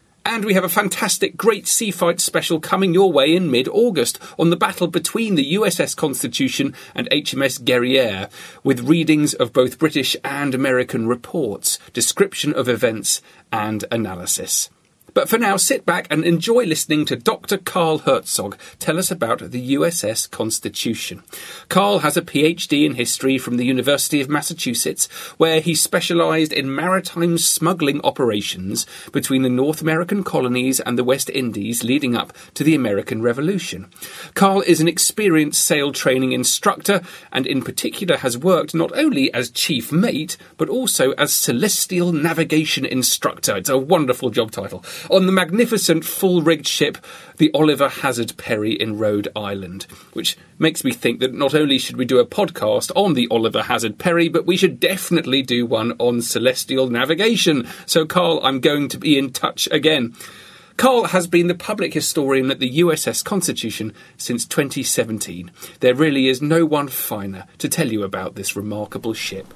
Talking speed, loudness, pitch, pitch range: 165 wpm, -18 LUFS, 155 Hz, 130-175 Hz